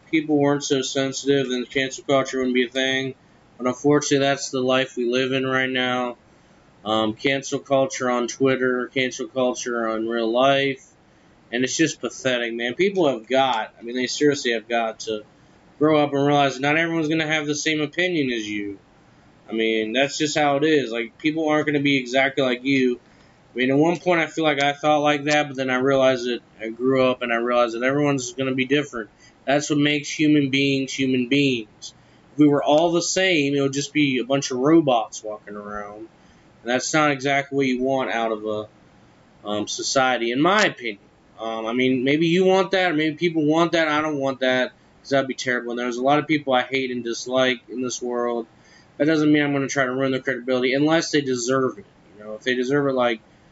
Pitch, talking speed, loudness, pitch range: 135 Hz, 225 wpm, -21 LUFS, 125-145 Hz